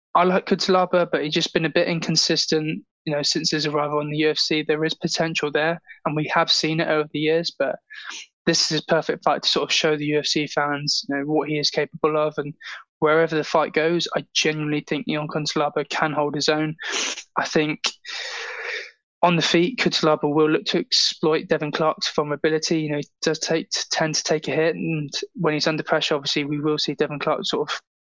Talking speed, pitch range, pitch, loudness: 215 wpm, 150-165 Hz, 155 Hz, -22 LUFS